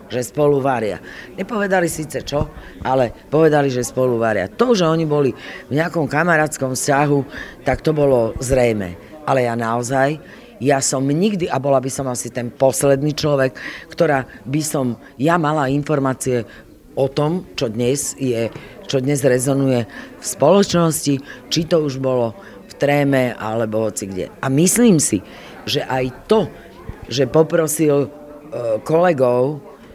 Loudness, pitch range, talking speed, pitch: -18 LUFS, 125-155 Hz, 140 wpm, 140 Hz